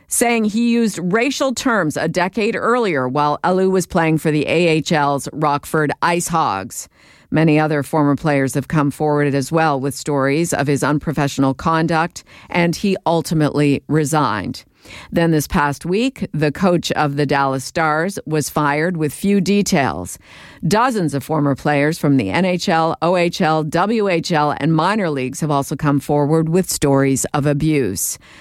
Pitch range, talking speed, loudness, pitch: 145-175 Hz, 150 wpm, -17 LUFS, 155 Hz